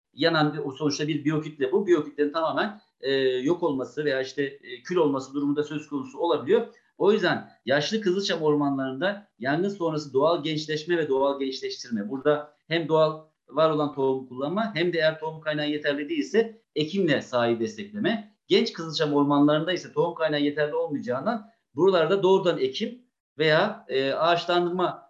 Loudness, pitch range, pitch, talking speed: -25 LUFS, 145-190 Hz, 155 Hz, 155 wpm